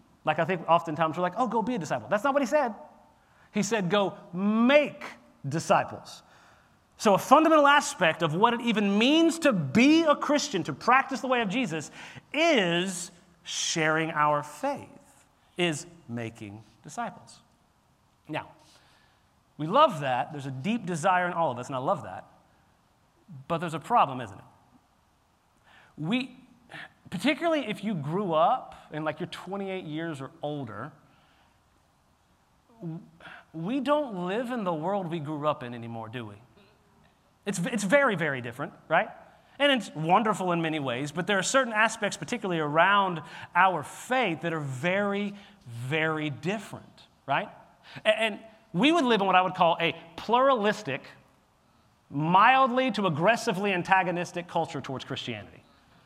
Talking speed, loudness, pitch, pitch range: 150 wpm, -26 LUFS, 180 Hz, 155-230 Hz